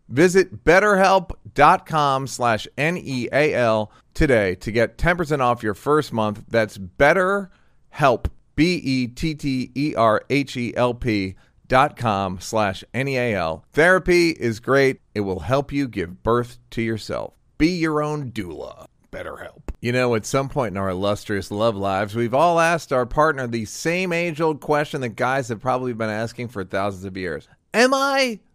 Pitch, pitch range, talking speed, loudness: 125 Hz, 110-155 Hz, 140 wpm, -21 LUFS